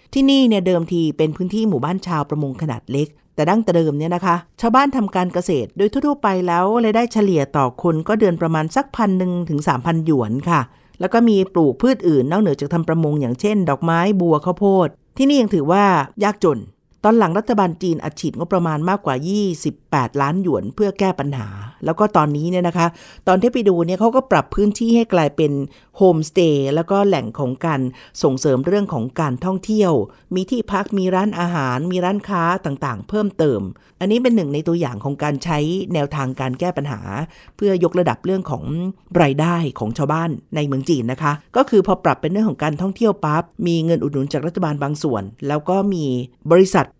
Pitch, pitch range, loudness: 170 Hz, 150-195 Hz, -18 LUFS